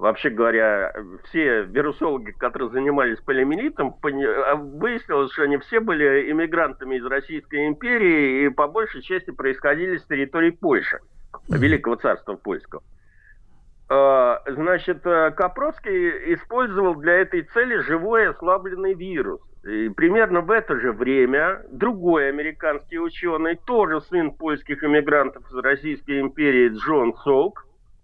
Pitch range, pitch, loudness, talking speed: 140-215 Hz, 160 Hz, -21 LUFS, 120 wpm